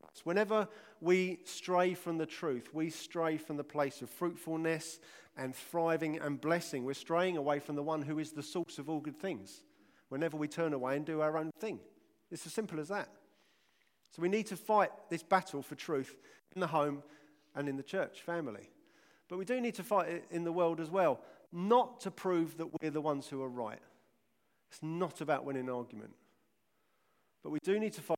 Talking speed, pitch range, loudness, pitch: 205 wpm, 150-180 Hz, -36 LUFS, 165 Hz